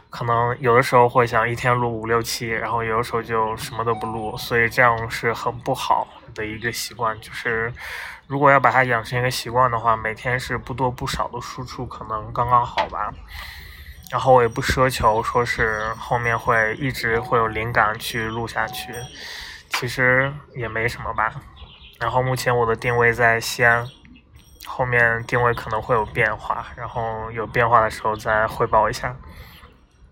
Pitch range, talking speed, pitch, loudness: 110-125 Hz, 265 characters per minute, 115 Hz, -21 LUFS